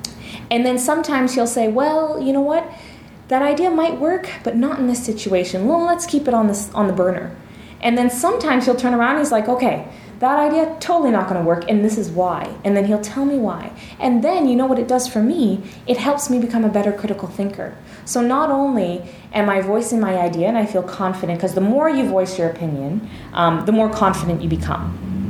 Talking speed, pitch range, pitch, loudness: 225 wpm, 195-265 Hz, 225 Hz, -18 LUFS